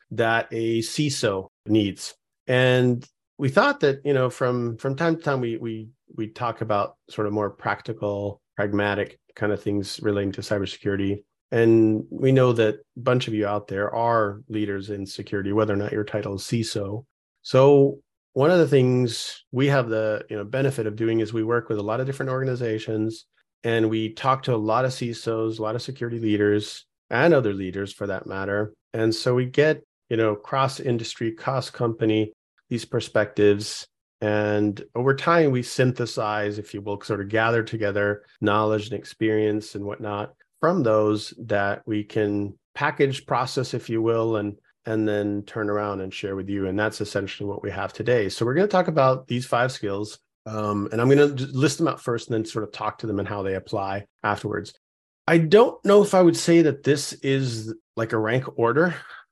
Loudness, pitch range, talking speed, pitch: -24 LUFS, 105-125 Hz, 195 wpm, 110 Hz